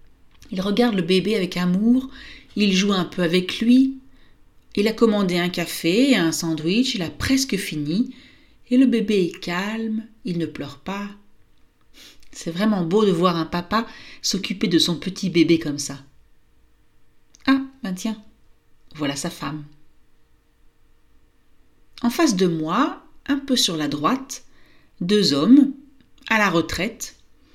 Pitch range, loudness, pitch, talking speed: 170-245 Hz, -21 LUFS, 200 Hz, 145 wpm